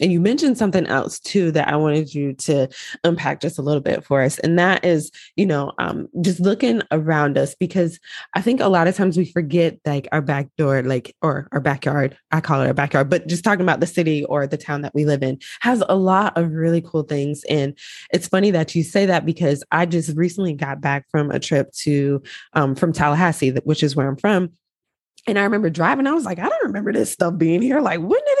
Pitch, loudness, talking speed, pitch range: 165 Hz, -19 LUFS, 235 wpm, 145-180 Hz